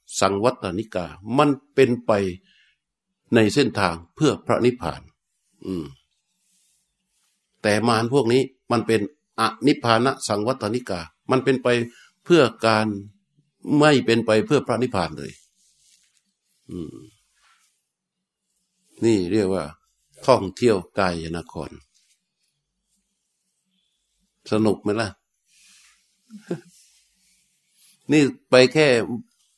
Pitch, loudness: 130 Hz, -21 LUFS